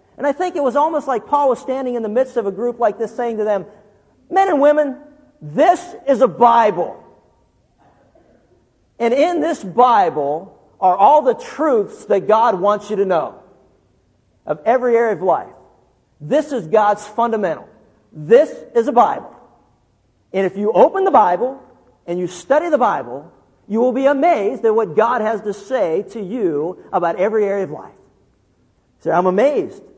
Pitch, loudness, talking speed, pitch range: 235 Hz, -17 LUFS, 170 wpm, 205-290 Hz